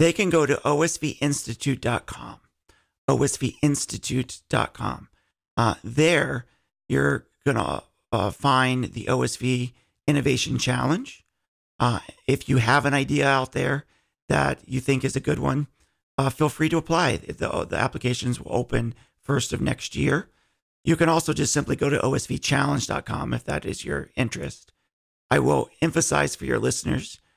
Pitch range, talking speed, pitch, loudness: 125-150 Hz, 140 wpm, 135 Hz, -24 LUFS